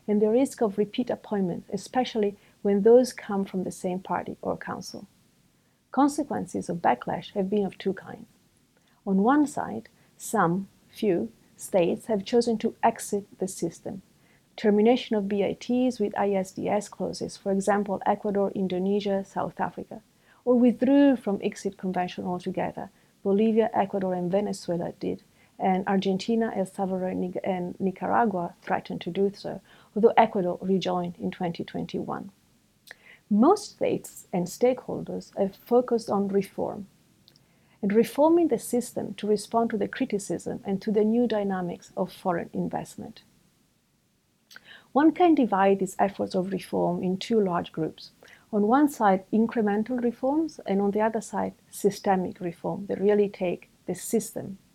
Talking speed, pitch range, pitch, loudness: 140 wpm, 190-230 Hz, 205 Hz, -26 LUFS